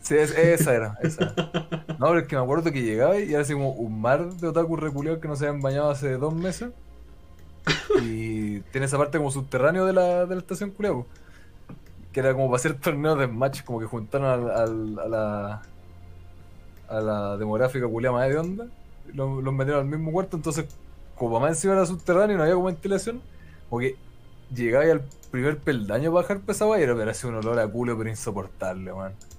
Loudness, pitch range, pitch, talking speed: -25 LUFS, 110-165 Hz, 135 Hz, 205 wpm